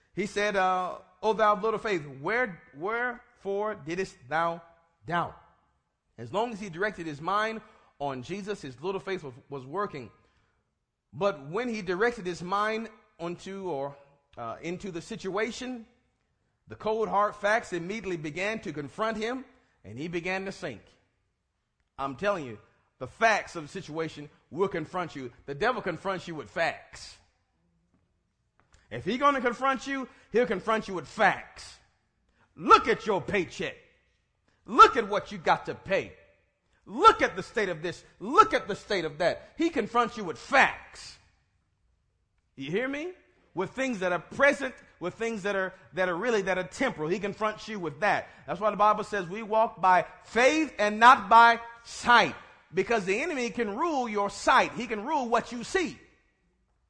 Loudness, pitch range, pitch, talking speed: -27 LUFS, 160-225 Hz, 195 Hz, 165 wpm